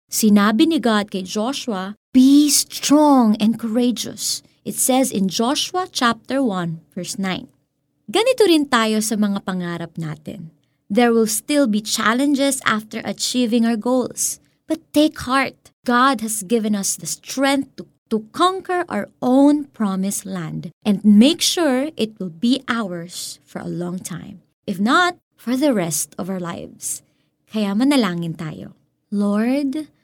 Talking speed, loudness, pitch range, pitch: 145 wpm, -19 LUFS, 190-265 Hz, 220 Hz